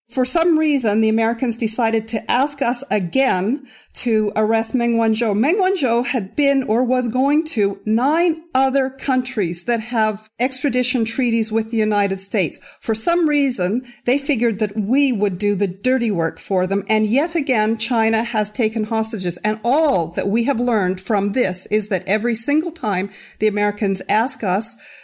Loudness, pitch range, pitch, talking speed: -19 LUFS, 210-260 Hz, 225 Hz, 170 wpm